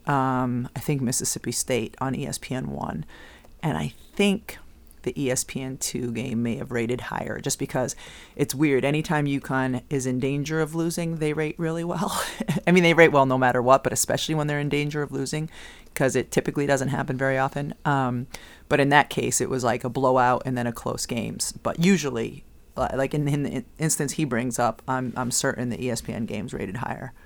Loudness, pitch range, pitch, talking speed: -25 LUFS, 125-150 Hz, 135 Hz, 195 wpm